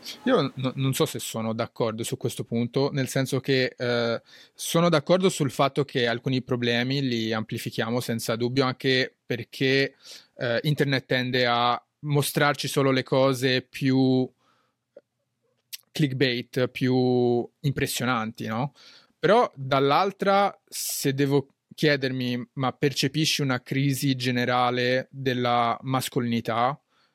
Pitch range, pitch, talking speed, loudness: 120-140 Hz, 130 Hz, 115 wpm, -25 LUFS